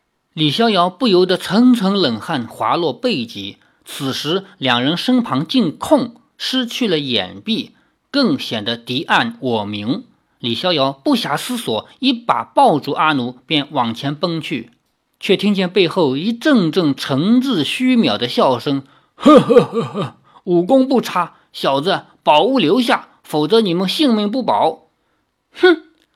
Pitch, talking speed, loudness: 195 Hz, 205 characters per minute, -16 LUFS